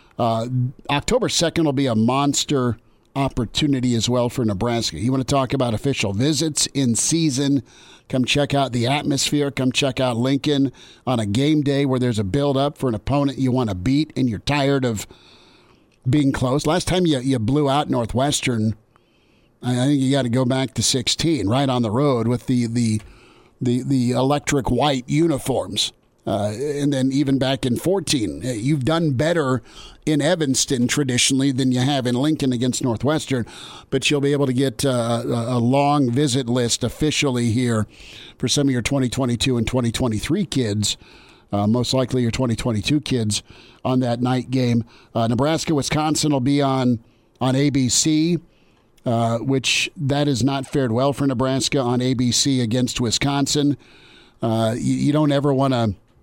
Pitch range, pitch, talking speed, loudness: 120-140 Hz, 130 Hz, 170 wpm, -20 LUFS